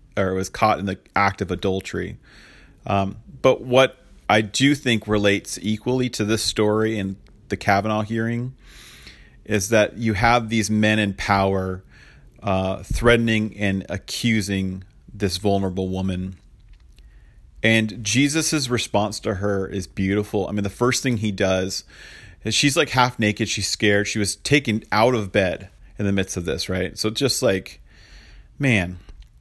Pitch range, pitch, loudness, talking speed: 95-115 Hz, 105 Hz, -21 LUFS, 155 wpm